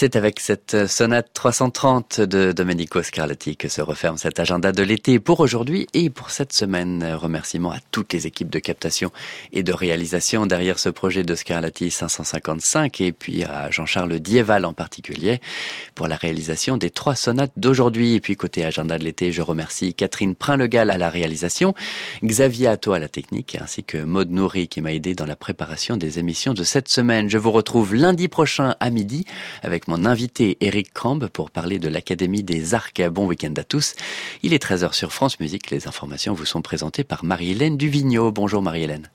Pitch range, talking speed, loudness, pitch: 85-120 Hz, 190 wpm, -21 LUFS, 95 Hz